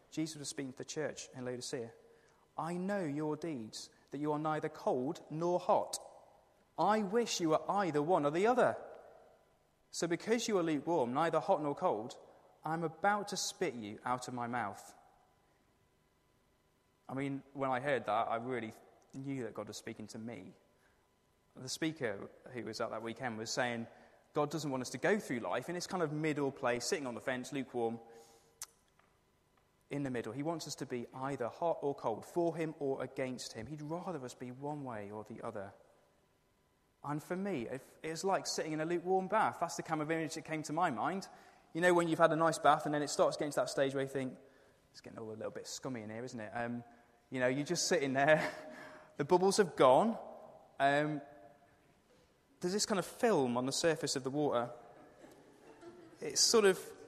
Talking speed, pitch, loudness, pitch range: 200 wpm, 145 Hz, -36 LUFS, 125-170 Hz